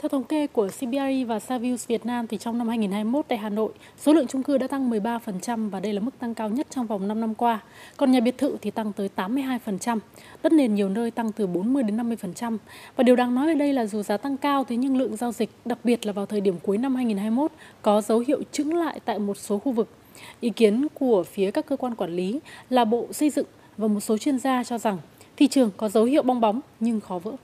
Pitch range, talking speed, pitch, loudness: 215-265 Hz, 255 wpm, 235 Hz, -25 LUFS